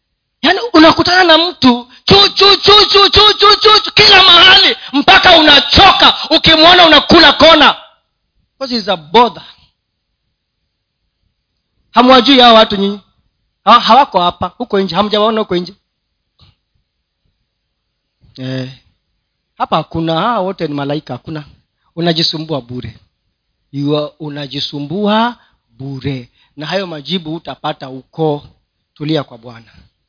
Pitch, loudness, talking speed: 190 Hz, -7 LUFS, 100 wpm